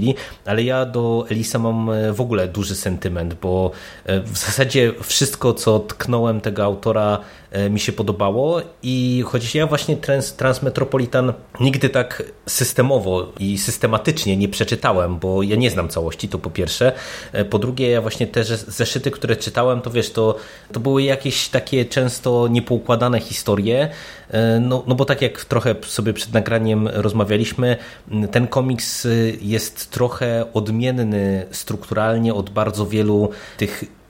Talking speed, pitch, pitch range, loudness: 135 wpm, 115 Hz, 105-125 Hz, -19 LUFS